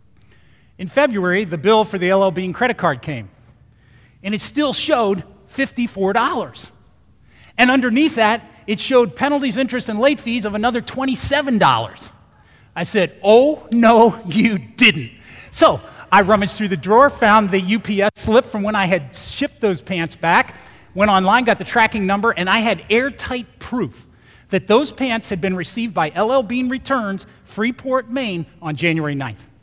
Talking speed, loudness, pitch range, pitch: 160 wpm, -17 LUFS, 185-245 Hz, 215 Hz